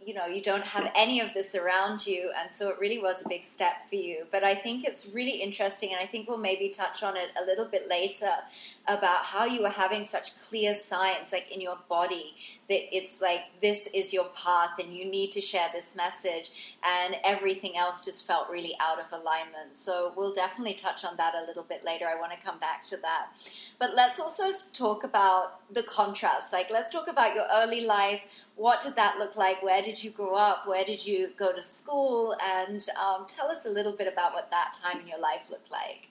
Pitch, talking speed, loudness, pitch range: 195 Hz, 225 wpm, -29 LUFS, 180-210 Hz